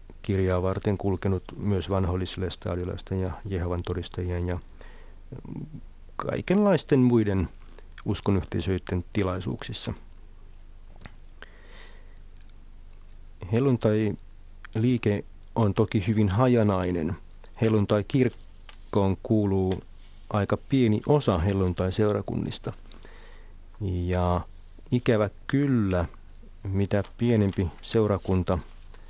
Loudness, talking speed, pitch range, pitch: -27 LUFS, 70 wpm, 80-105 Hz, 95 Hz